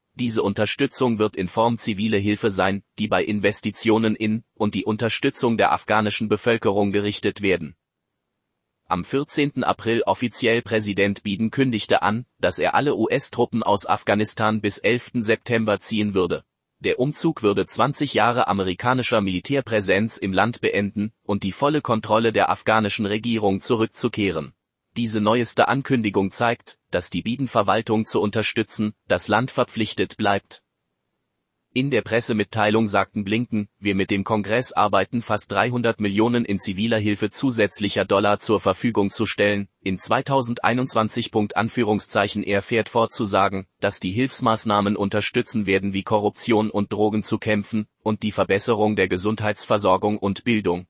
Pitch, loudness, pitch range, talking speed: 110 Hz, -22 LUFS, 100-115 Hz, 135 wpm